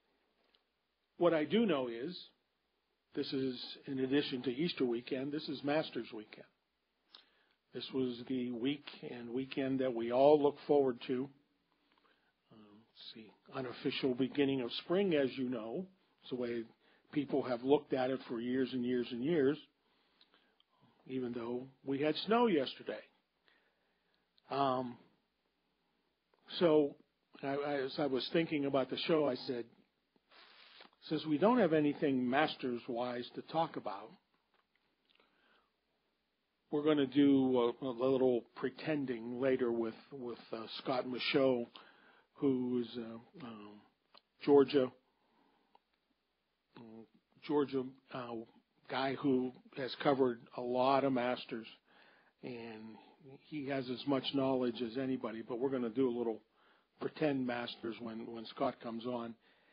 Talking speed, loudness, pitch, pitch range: 135 wpm, -36 LUFS, 130 Hz, 120-140 Hz